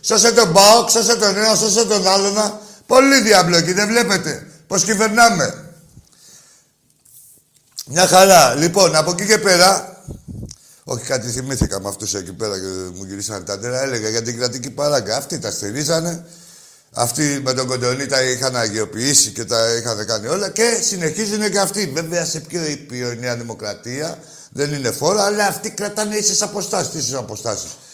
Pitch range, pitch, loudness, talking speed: 125-205 Hz, 160 Hz, -16 LUFS, 160 wpm